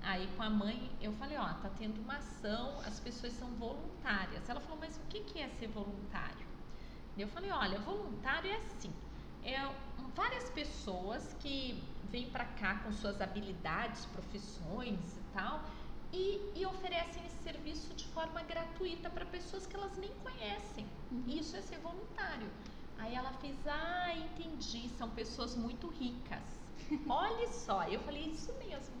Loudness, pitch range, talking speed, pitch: -42 LUFS, 215-330 Hz, 160 wpm, 255 Hz